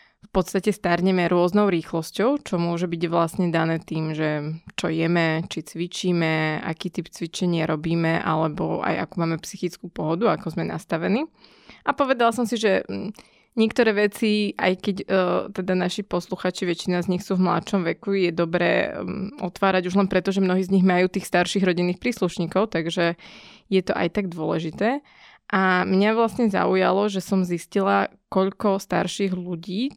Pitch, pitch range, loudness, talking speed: 185 Hz, 170-200 Hz, -23 LUFS, 160 wpm